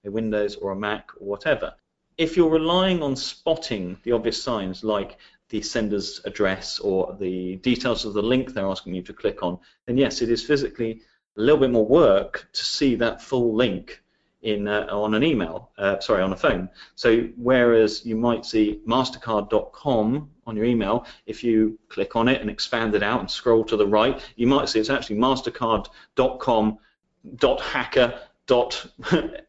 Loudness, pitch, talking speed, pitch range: -23 LUFS, 115 Hz, 175 wpm, 105-125 Hz